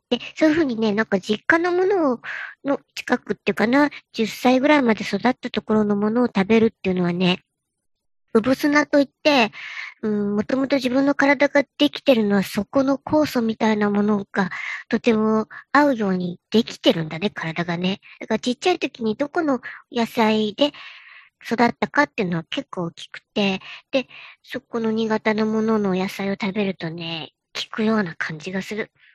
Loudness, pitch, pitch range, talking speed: -21 LUFS, 220 Hz, 205-275 Hz, 340 characters per minute